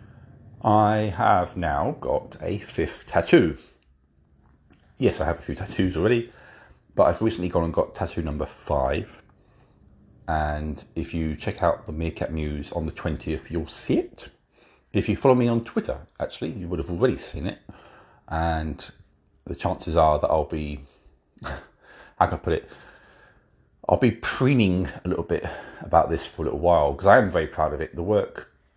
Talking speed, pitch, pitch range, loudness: 175 wpm, 80 Hz, 75-100 Hz, -24 LUFS